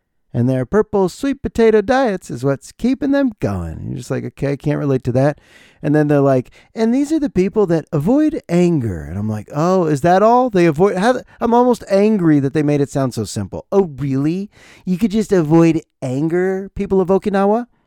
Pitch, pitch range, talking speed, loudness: 175 Hz, 140-215 Hz, 210 wpm, -16 LUFS